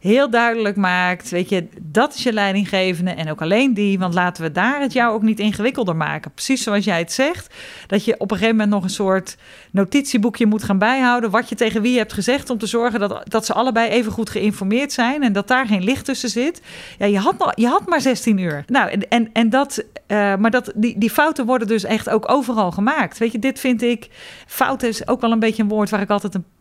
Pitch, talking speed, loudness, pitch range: 225 Hz, 245 wpm, -18 LUFS, 200-245 Hz